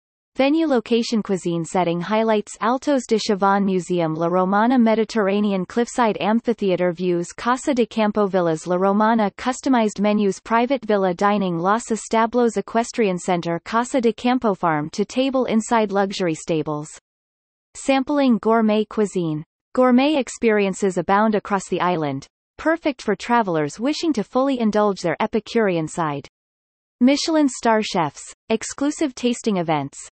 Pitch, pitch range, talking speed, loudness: 210 Hz, 180-235 Hz, 125 wpm, -20 LUFS